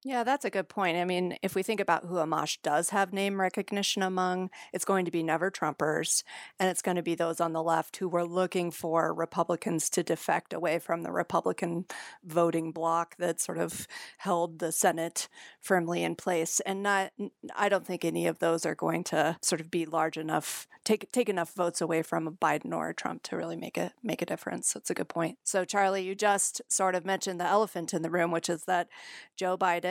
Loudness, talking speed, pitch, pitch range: -30 LUFS, 225 wpm, 175 Hz, 165-190 Hz